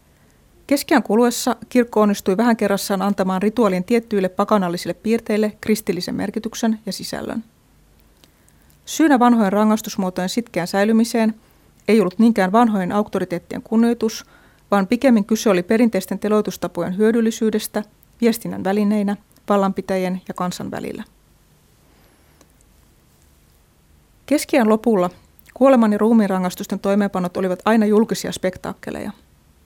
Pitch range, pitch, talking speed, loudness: 190-230 Hz, 210 Hz, 100 wpm, -19 LUFS